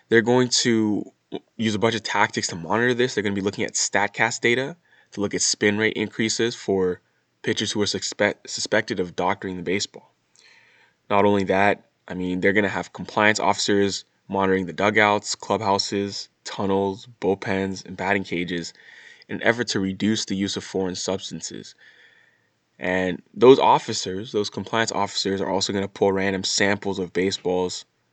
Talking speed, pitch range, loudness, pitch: 170 wpm, 95-105 Hz, -23 LUFS, 100 Hz